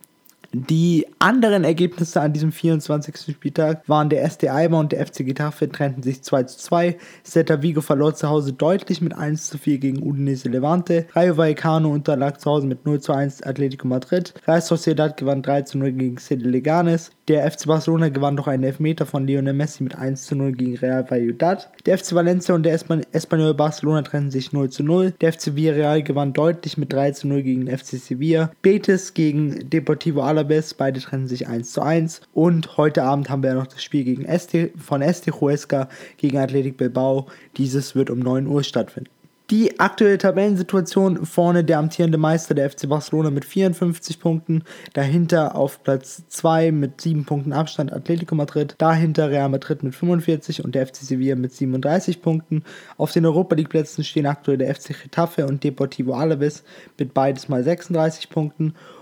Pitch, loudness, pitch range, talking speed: 155 Hz, -20 LUFS, 140-165 Hz, 180 wpm